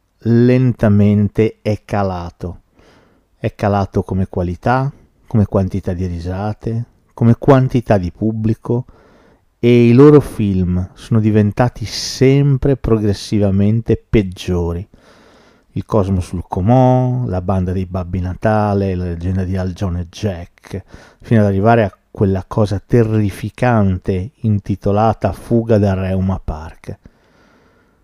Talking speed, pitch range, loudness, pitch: 110 wpm, 95-115 Hz, -16 LUFS, 105 Hz